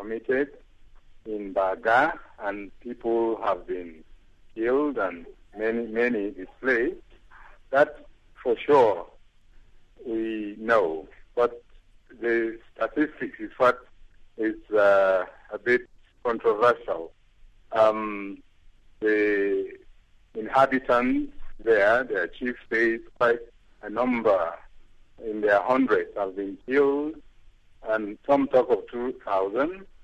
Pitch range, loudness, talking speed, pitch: 100-125 Hz, -25 LUFS, 95 wpm, 110 Hz